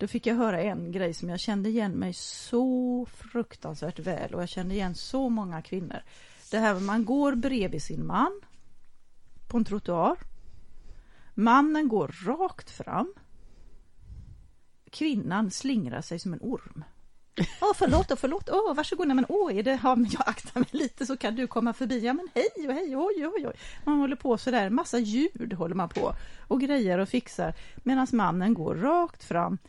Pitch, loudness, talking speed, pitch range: 240 Hz, -28 LUFS, 185 wpm, 200-275 Hz